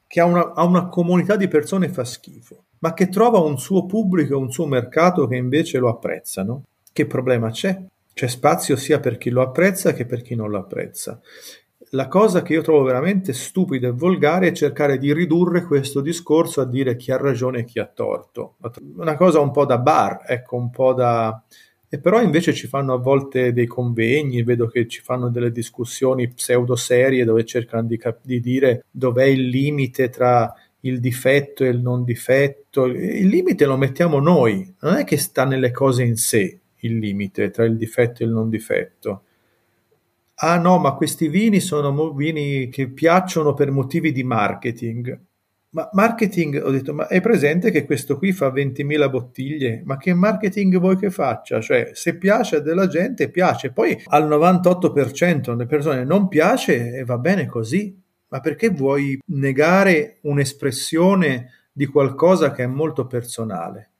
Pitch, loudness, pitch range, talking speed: 140 Hz, -19 LUFS, 125-170 Hz, 180 wpm